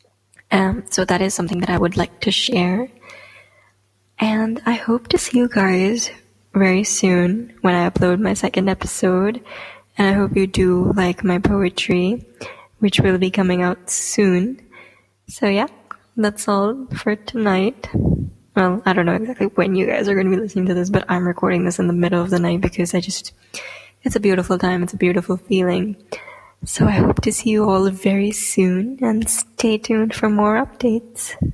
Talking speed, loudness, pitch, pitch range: 185 wpm, -18 LUFS, 195 Hz, 180-220 Hz